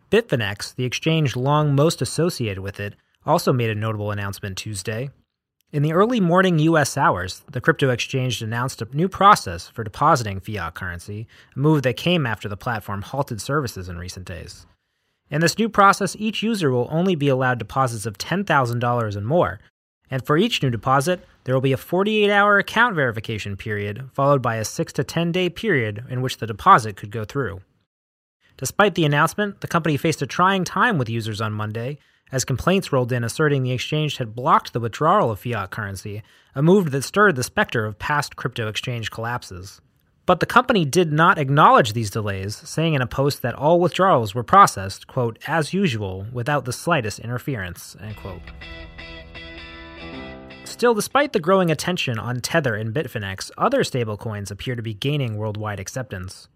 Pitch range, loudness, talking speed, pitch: 105-160 Hz, -21 LUFS, 180 wpm, 125 Hz